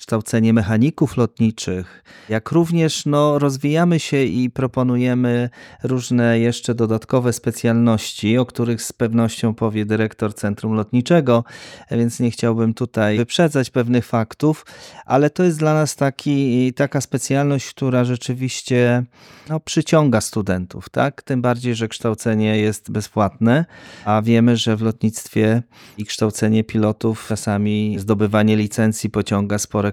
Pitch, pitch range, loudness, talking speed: 120 Hz, 110-130 Hz, -19 LUFS, 125 wpm